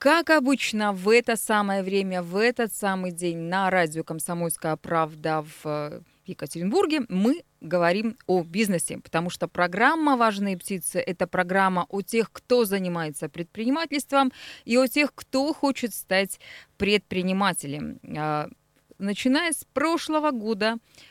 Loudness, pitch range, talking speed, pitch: -25 LUFS, 175-245 Hz, 120 wpm, 195 Hz